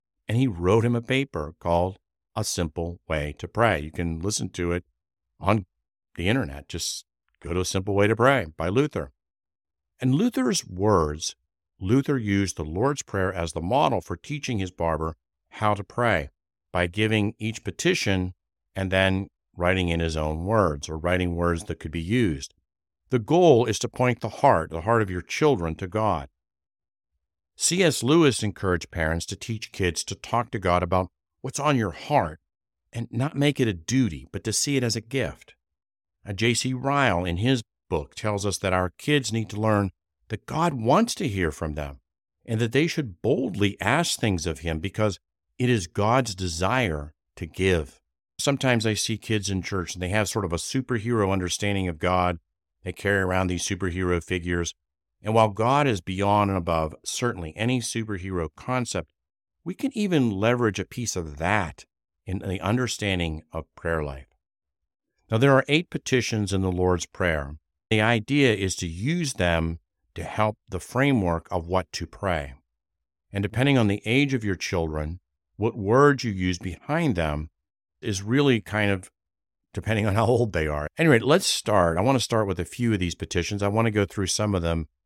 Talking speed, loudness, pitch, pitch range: 185 wpm, -25 LUFS, 95 Hz, 85-115 Hz